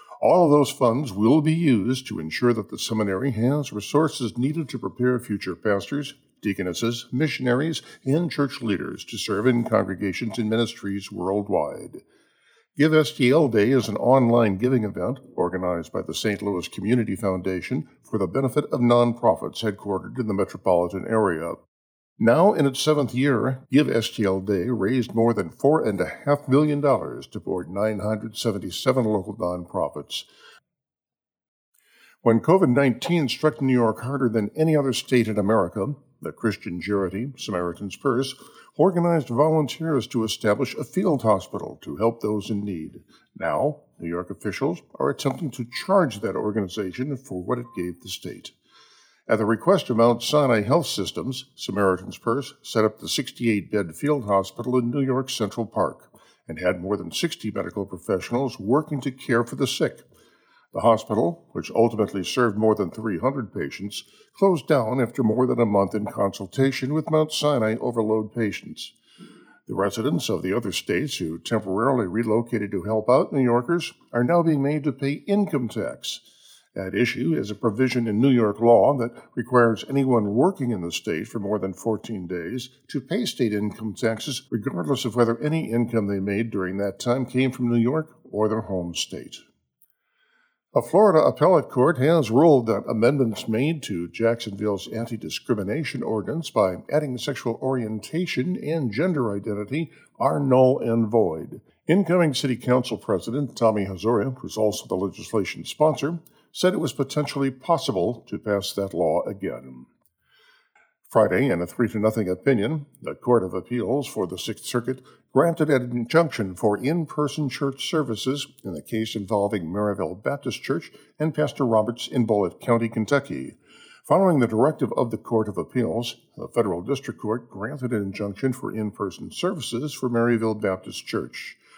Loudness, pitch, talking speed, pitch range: -24 LUFS, 120 Hz, 160 wpm, 105-140 Hz